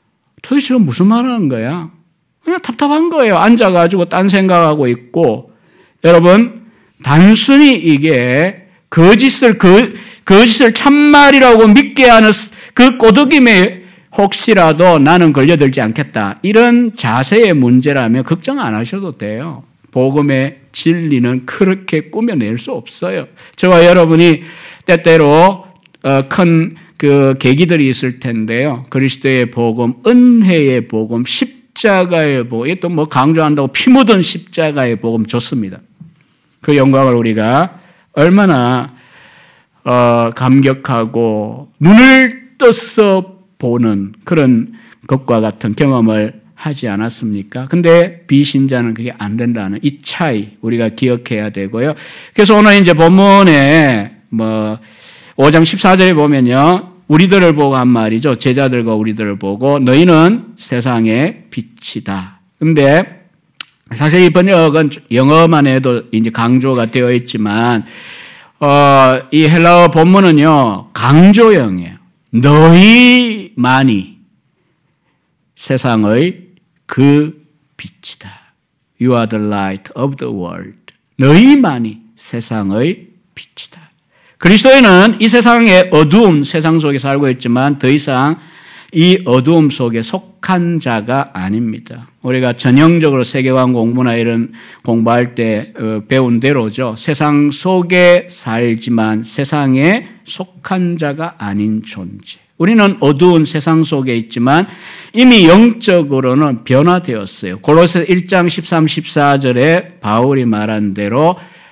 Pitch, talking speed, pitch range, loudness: 150 Hz, 255 characters per minute, 125-180 Hz, -10 LUFS